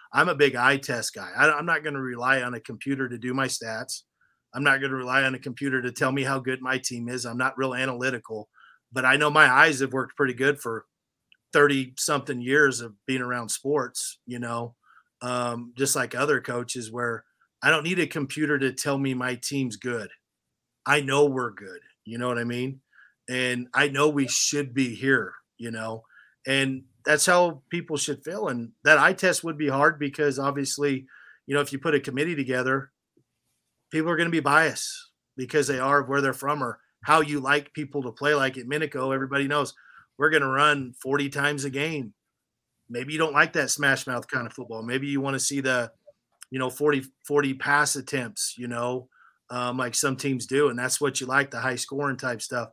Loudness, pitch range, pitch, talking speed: -25 LUFS, 125-145 Hz, 135 Hz, 215 wpm